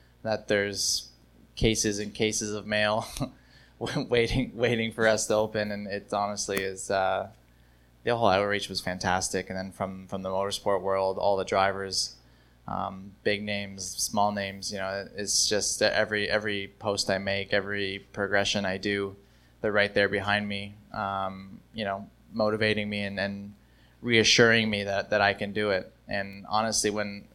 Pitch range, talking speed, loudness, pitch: 95-105 Hz, 160 wpm, -27 LUFS, 100 Hz